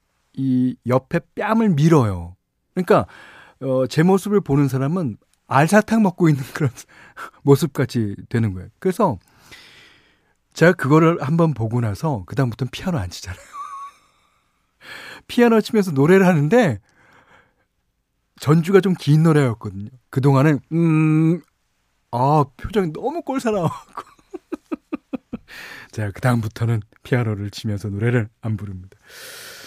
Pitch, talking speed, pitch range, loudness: 145 Hz, 265 characters per minute, 115-190 Hz, -19 LUFS